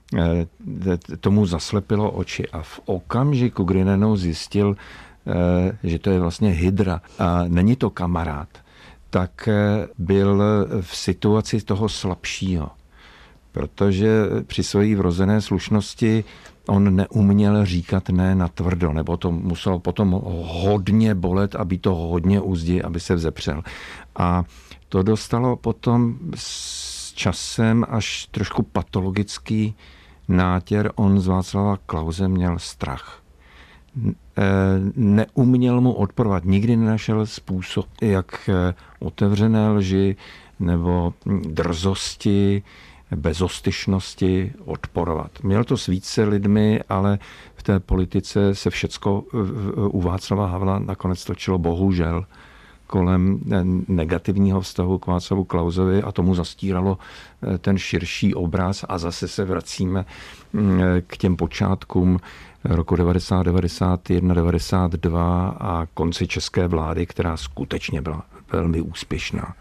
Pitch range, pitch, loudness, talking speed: 85-100 Hz, 95 Hz, -21 LUFS, 110 wpm